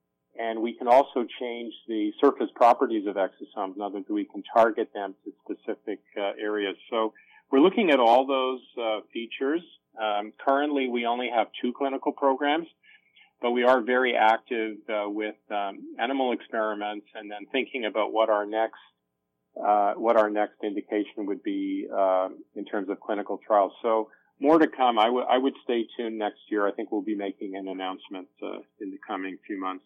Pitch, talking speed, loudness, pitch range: 110 Hz, 185 wpm, -26 LUFS, 105-130 Hz